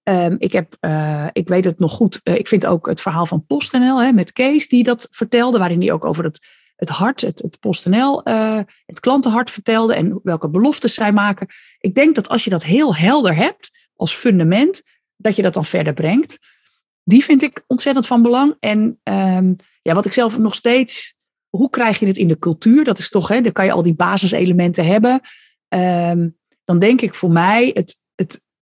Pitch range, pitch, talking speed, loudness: 180-245 Hz, 210 Hz, 205 wpm, -16 LUFS